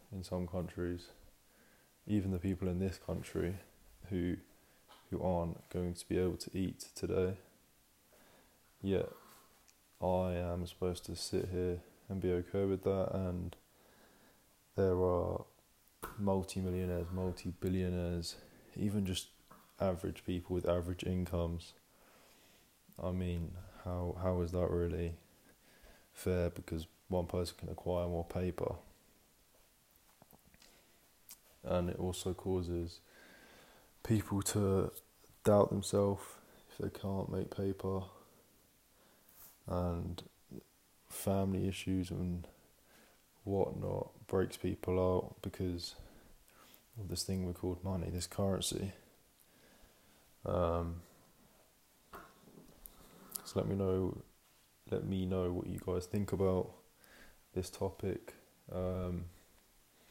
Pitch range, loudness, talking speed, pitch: 90-95 Hz, -38 LUFS, 105 wpm, 90 Hz